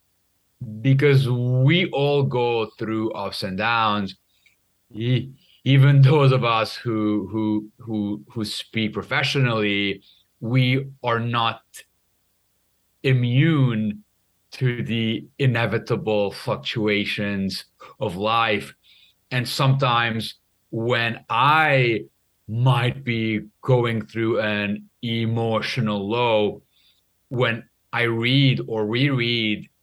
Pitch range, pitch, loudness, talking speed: 100-125 Hz, 115 Hz, -22 LUFS, 90 wpm